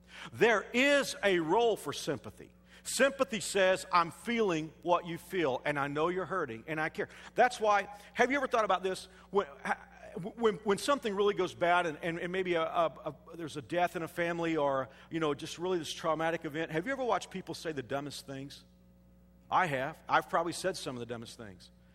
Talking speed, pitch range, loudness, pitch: 210 wpm, 150-200 Hz, -32 LUFS, 170 Hz